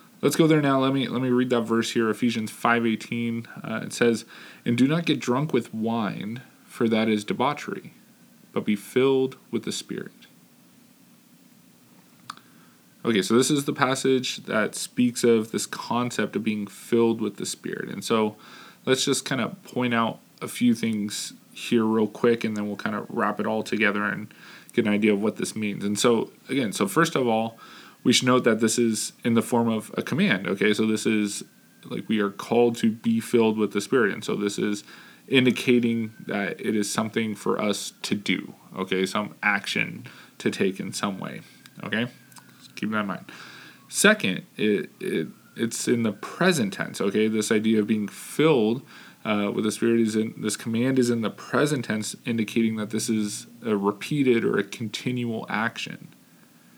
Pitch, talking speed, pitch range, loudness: 115 Hz, 190 wpm, 110-125 Hz, -25 LUFS